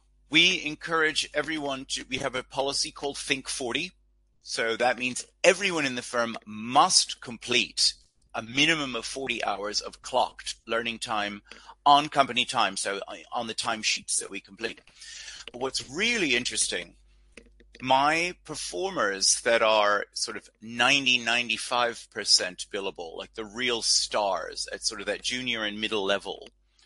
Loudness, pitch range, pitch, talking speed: -26 LUFS, 110-140 Hz, 125 Hz, 140 wpm